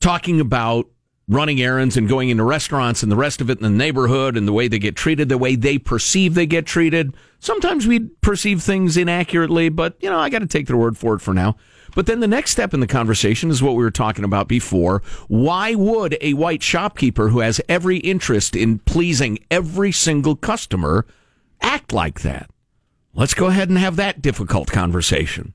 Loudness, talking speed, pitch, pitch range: -18 LUFS, 205 wpm, 135 Hz, 115-175 Hz